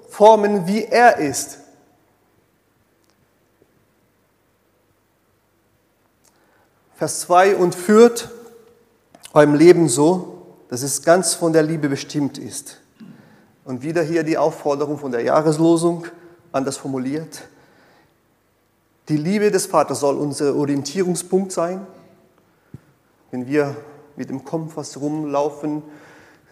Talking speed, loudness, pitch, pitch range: 95 wpm, -18 LUFS, 155 Hz, 140-175 Hz